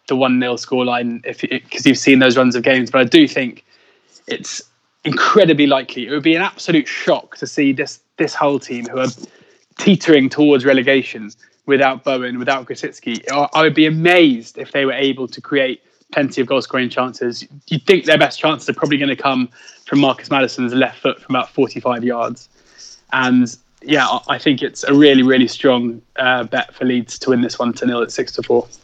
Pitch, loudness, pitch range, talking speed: 130 Hz, -15 LUFS, 125-145 Hz, 200 wpm